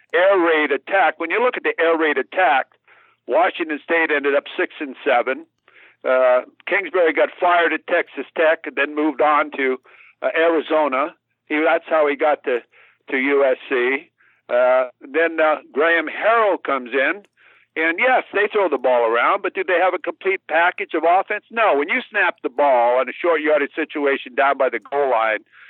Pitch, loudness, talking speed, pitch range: 160 Hz, -19 LUFS, 185 wpm, 140-185 Hz